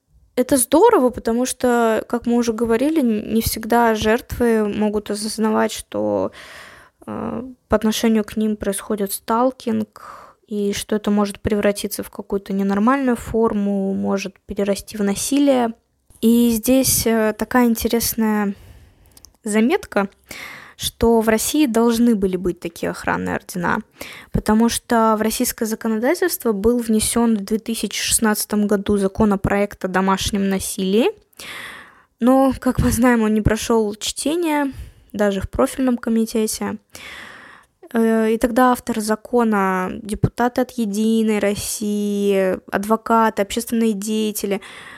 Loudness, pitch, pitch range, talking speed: -19 LUFS, 220 Hz, 205-235 Hz, 115 wpm